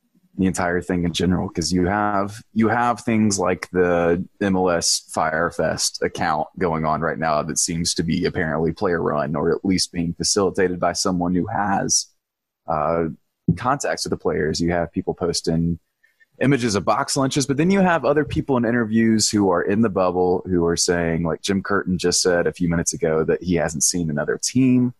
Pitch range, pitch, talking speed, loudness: 85-110 Hz, 90 Hz, 190 wpm, -20 LUFS